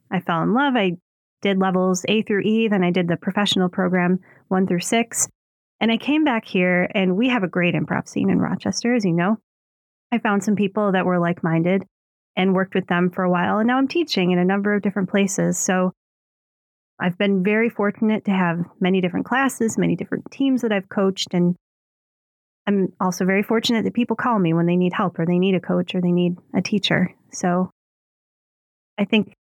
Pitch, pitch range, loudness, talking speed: 190 Hz, 180-215 Hz, -21 LUFS, 210 wpm